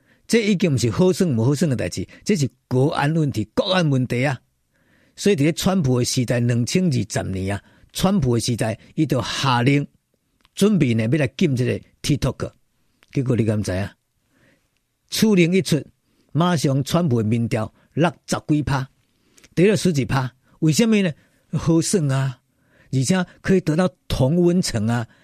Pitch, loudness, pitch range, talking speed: 135 Hz, -20 LUFS, 120-170 Hz, 250 characters per minute